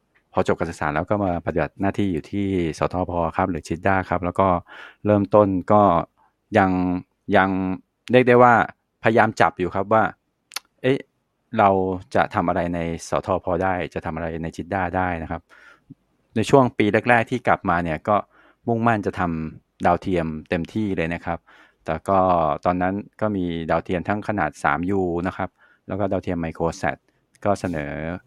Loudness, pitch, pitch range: -22 LUFS, 95 Hz, 85-100 Hz